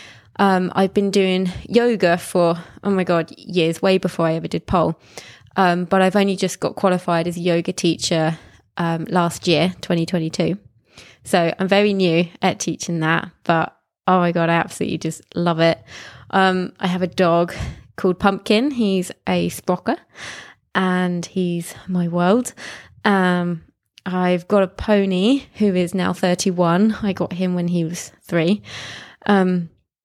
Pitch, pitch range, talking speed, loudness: 180 Hz, 170-195 Hz, 155 wpm, -19 LUFS